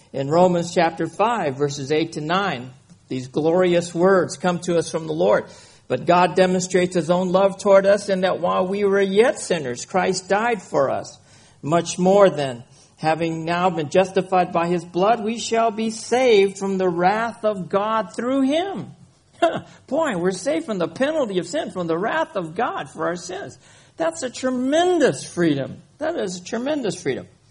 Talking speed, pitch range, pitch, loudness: 180 wpm, 165-220 Hz, 185 Hz, -21 LUFS